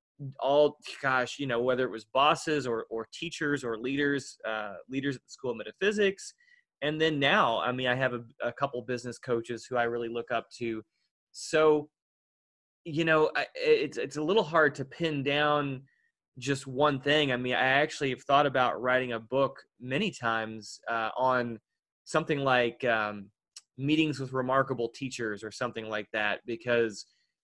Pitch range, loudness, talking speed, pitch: 115-150 Hz, -29 LUFS, 175 wpm, 130 Hz